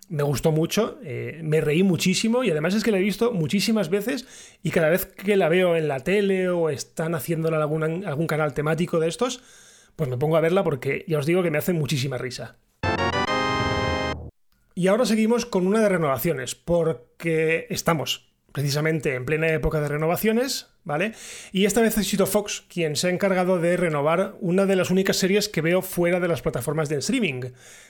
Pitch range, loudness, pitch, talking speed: 155-195 Hz, -23 LUFS, 170 Hz, 195 wpm